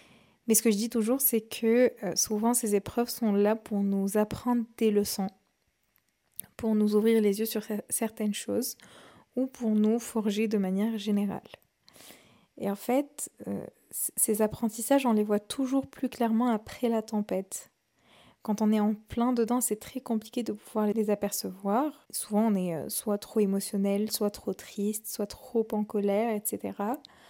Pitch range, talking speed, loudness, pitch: 210-235 Hz, 165 wpm, -29 LUFS, 220 Hz